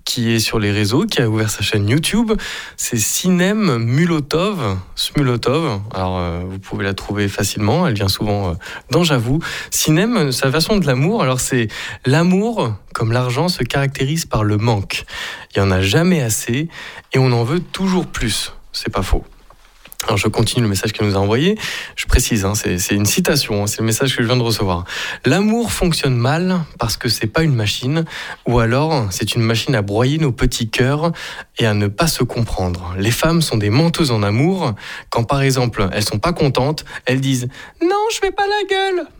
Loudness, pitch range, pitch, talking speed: -17 LUFS, 110-160 Hz, 125 Hz, 200 wpm